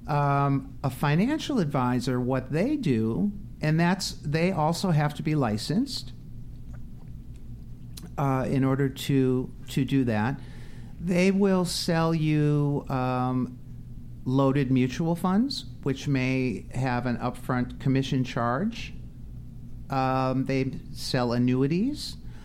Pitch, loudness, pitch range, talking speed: 135 Hz, -26 LUFS, 125-155 Hz, 110 wpm